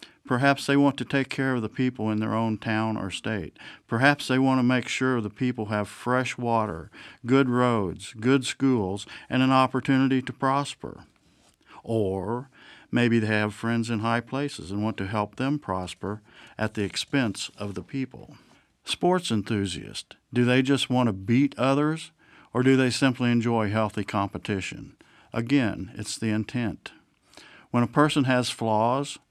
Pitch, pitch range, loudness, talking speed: 120 Hz, 110-135 Hz, -26 LUFS, 165 wpm